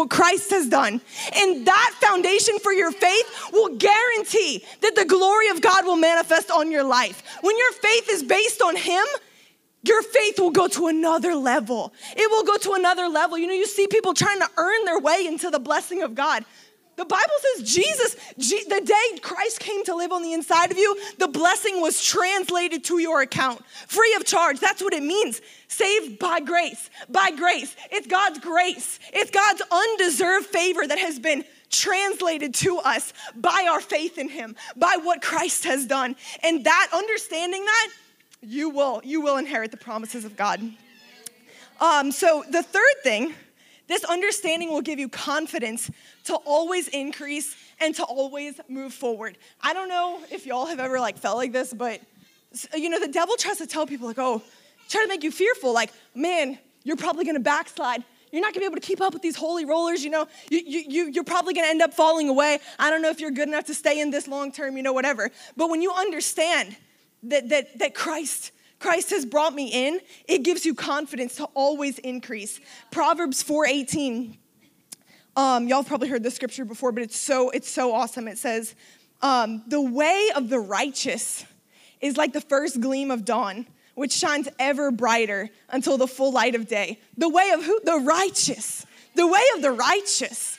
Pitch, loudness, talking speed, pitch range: 320 Hz, -22 LUFS, 195 wpm, 270-365 Hz